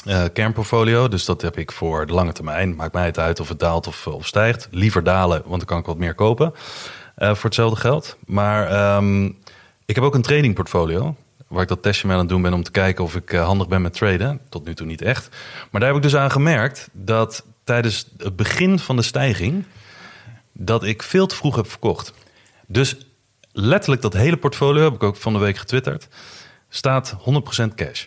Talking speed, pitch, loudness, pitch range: 215 wpm, 110 Hz, -19 LUFS, 90-130 Hz